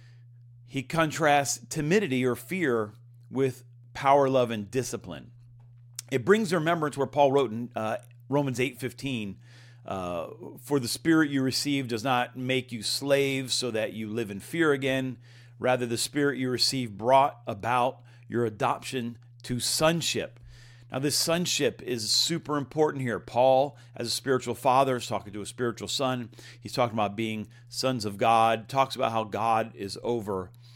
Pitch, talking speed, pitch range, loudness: 120 Hz, 160 wpm, 120-135 Hz, -27 LUFS